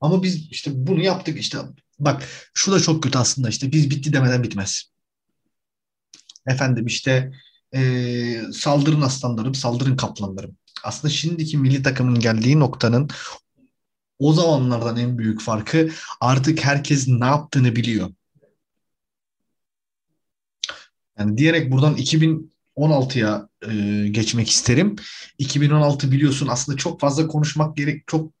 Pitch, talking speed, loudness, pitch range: 135 Hz, 115 wpm, -20 LUFS, 120-150 Hz